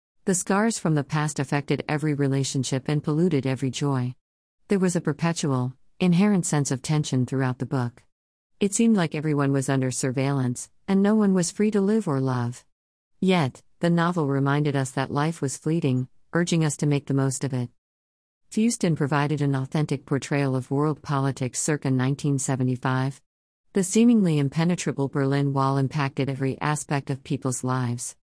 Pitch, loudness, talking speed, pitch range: 140 Hz, -24 LUFS, 165 wpm, 130-160 Hz